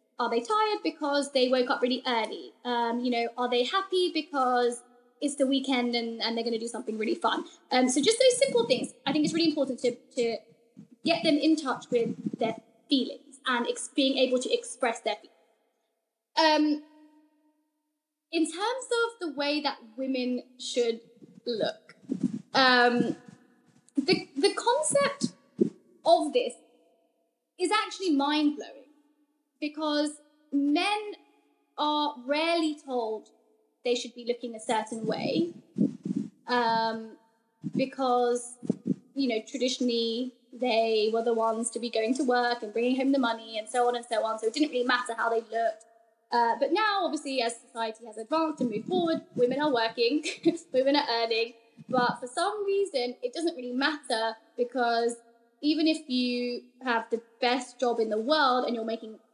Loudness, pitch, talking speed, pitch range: -28 LUFS, 250 Hz, 160 wpm, 235-300 Hz